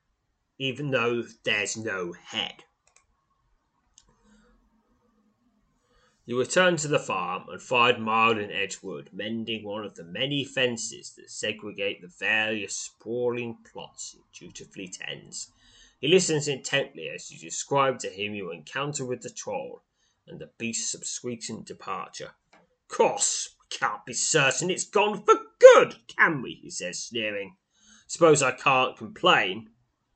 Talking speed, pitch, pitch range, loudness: 130 wpm, 125 Hz, 115-180 Hz, -25 LUFS